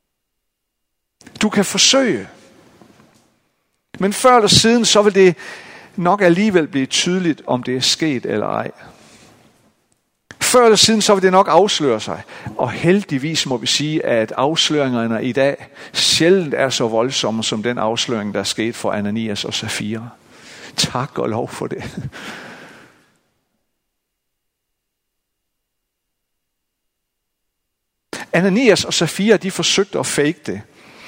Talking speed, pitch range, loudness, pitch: 125 wpm, 115-190 Hz, -16 LUFS, 150 Hz